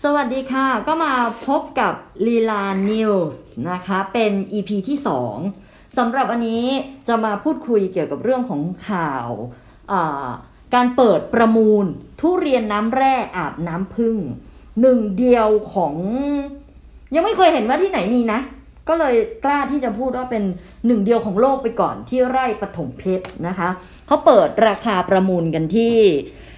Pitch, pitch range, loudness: 230 Hz, 195-265 Hz, -19 LUFS